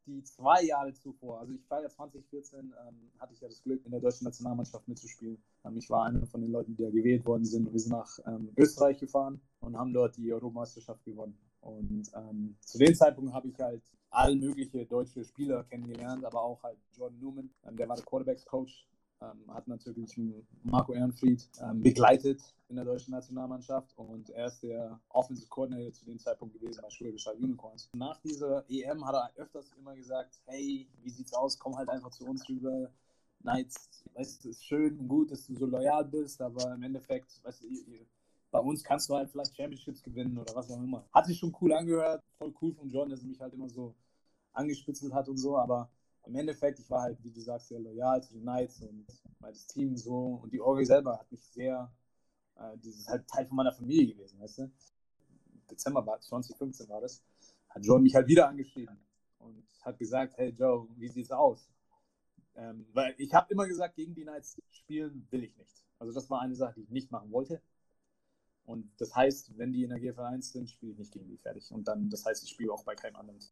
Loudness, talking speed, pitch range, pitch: -32 LUFS, 215 wpm, 115-135 Hz, 125 Hz